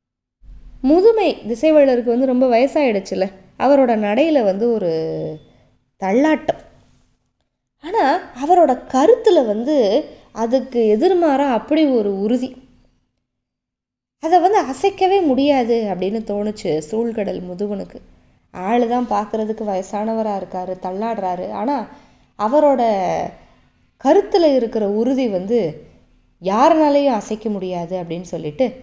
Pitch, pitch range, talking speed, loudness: 235 Hz, 200-285 Hz, 90 wpm, -17 LUFS